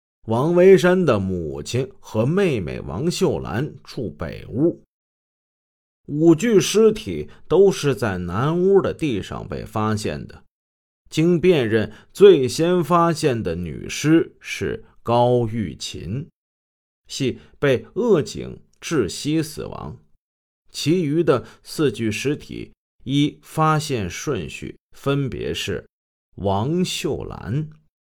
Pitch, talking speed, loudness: 135 Hz, 150 characters per minute, -20 LUFS